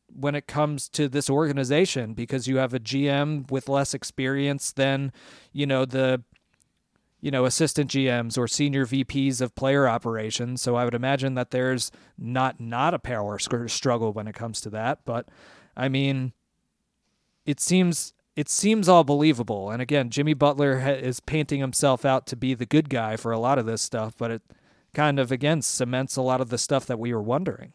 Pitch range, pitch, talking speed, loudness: 120-140 Hz, 130 Hz, 190 wpm, -25 LUFS